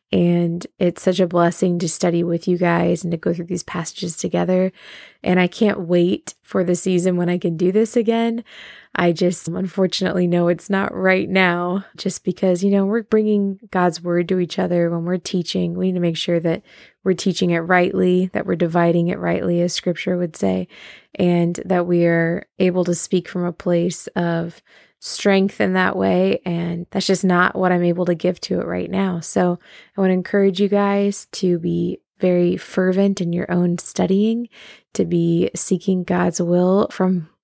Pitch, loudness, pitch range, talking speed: 180 Hz, -19 LUFS, 175-190 Hz, 190 wpm